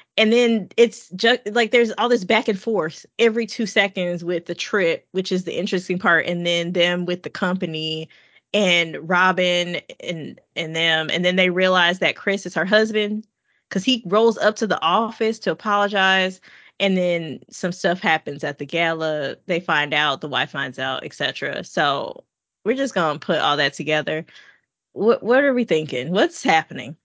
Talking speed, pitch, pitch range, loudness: 180 wpm, 185 Hz, 165-220 Hz, -20 LUFS